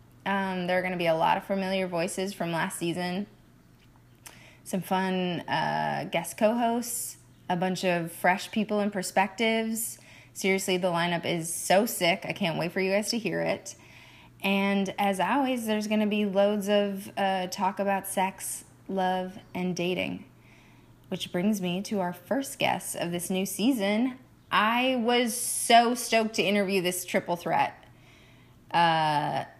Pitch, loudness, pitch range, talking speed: 190 Hz, -27 LUFS, 180-205 Hz, 160 wpm